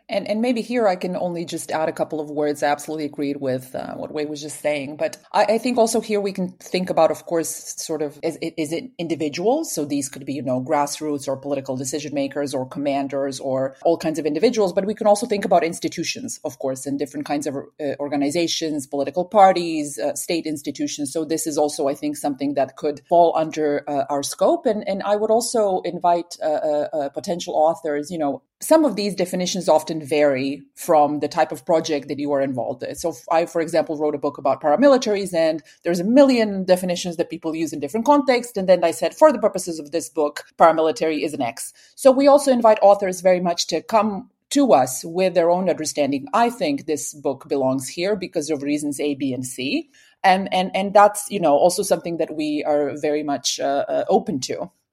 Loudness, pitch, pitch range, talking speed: -21 LUFS, 160 Hz, 145-195 Hz, 220 wpm